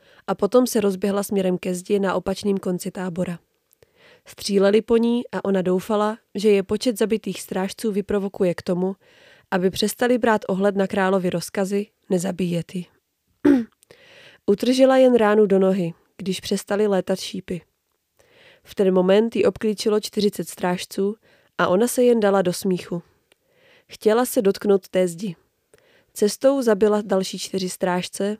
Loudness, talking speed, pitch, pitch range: -21 LUFS, 140 wpm, 200 Hz, 190-225 Hz